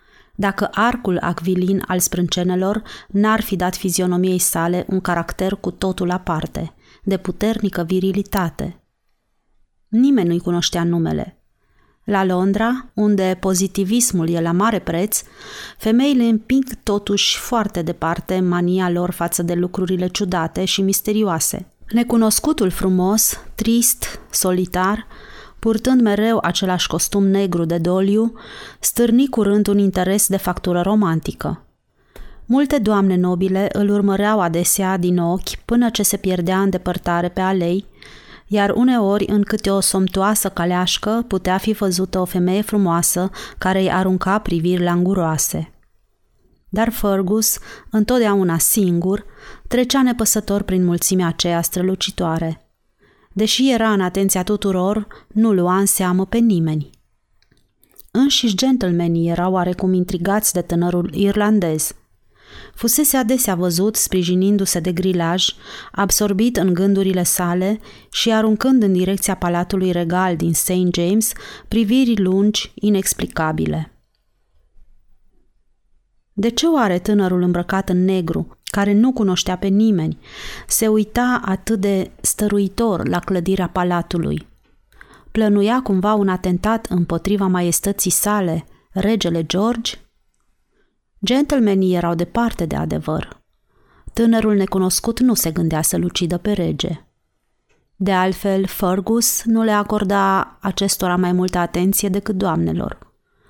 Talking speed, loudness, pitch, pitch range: 115 wpm, -18 LUFS, 190 Hz, 180-210 Hz